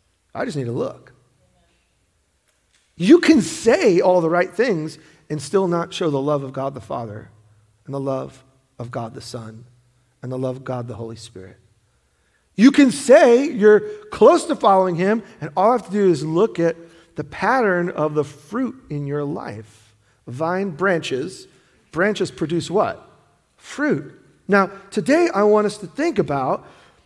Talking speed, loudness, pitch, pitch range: 170 wpm, -19 LUFS, 165 Hz, 130-200 Hz